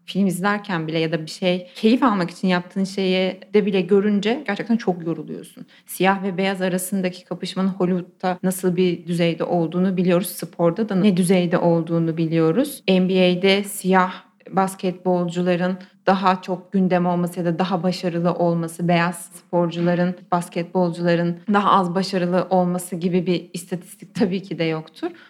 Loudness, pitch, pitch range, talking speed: -21 LUFS, 185 Hz, 175-190 Hz, 145 wpm